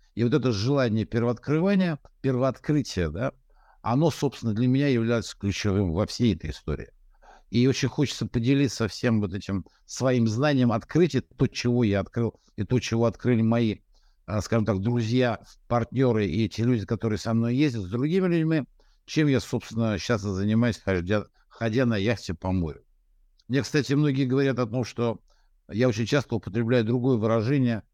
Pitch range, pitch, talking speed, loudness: 110-130 Hz, 120 Hz, 155 wpm, -26 LUFS